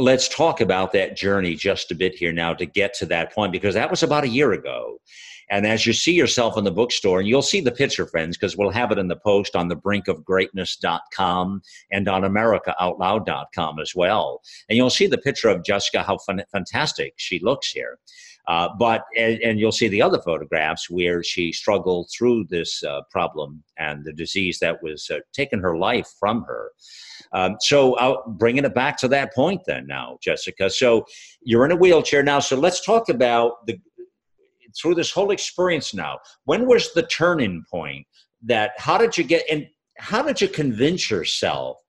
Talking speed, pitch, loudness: 195 wpm, 115 Hz, -21 LUFS